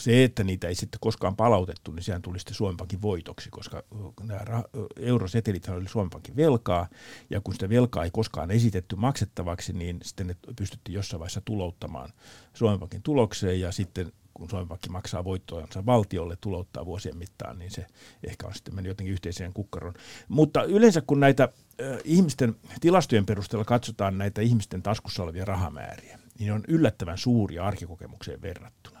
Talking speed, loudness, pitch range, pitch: 160 wpm, -27 LUFS, 90-115 Hz, 100 Hz